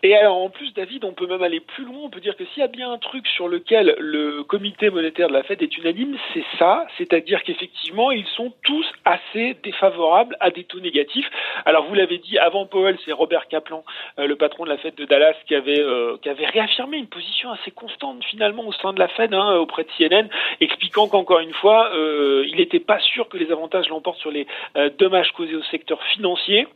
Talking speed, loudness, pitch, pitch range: 225 wpm, -20 LUFS, 190 Hz, 160-235 Hz